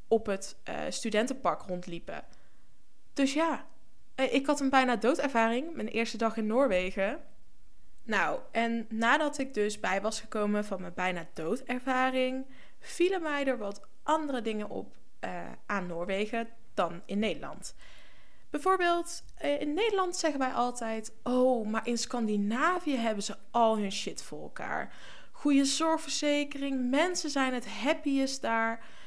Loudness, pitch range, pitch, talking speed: -31 LUFS, 215-285 Hz, 245 Hz, 140 wpm